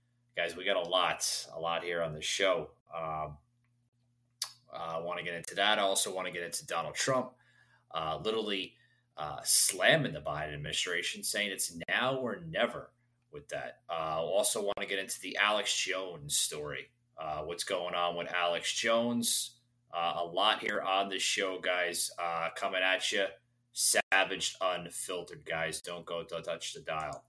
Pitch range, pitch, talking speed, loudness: 85-120 Hz, 95 Hz, 175 wpm, -31 LUFS